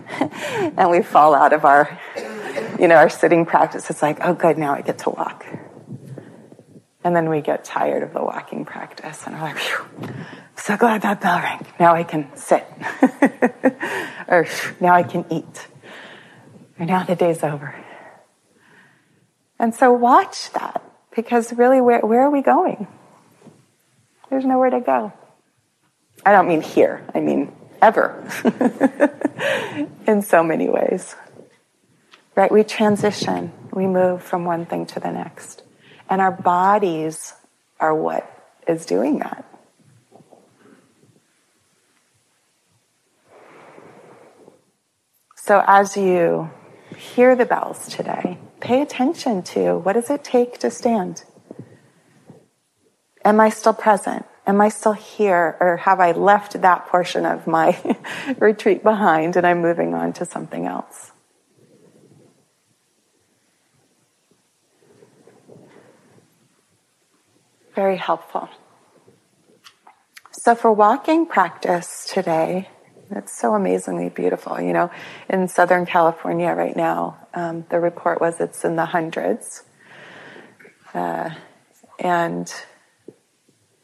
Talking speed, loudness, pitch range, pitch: 120 wpm, -19 LUFS, 170-230 Hz, 190 Hz